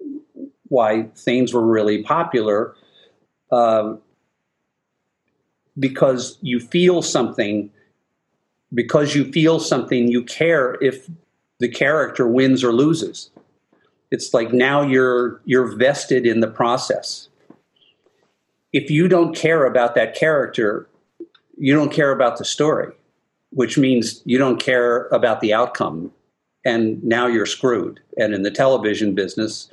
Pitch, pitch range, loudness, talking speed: 125 Hz, 115-150 Hz, -18 LUFS, 125 wpm